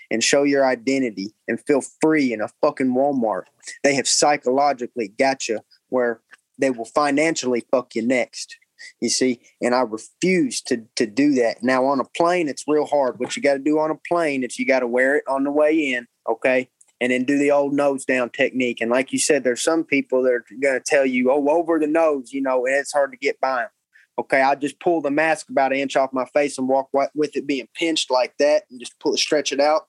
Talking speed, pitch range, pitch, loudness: 240 wpm, 125-150 Hz, 135 Hz, -20 LUFS